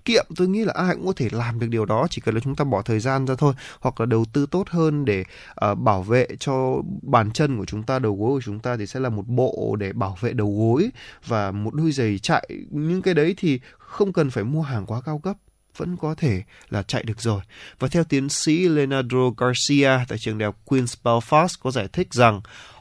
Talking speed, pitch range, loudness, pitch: 240 wpm, 110-150 Hz, -22 LUFS, 130 Hz